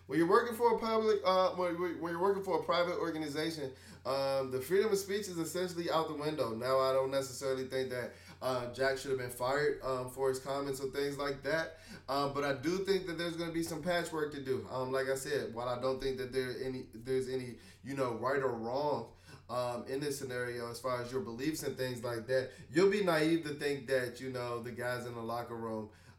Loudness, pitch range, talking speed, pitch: -35 LUFS, 125-165 Hz, 240 wpm, 135 Hz